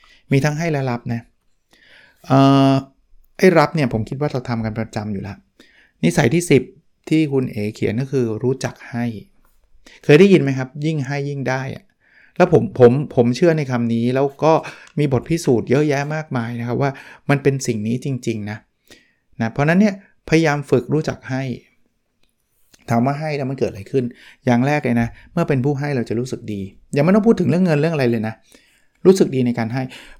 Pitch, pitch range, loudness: 135 Hz, 120-150 Hz, -18 LUFS